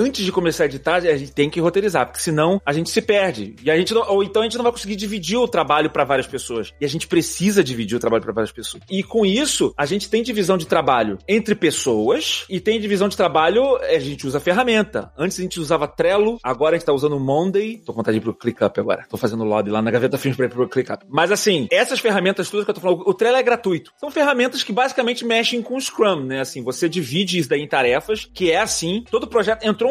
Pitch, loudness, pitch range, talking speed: 190 Hz, -19 LUFS, 145-220 Hz, 255 wpm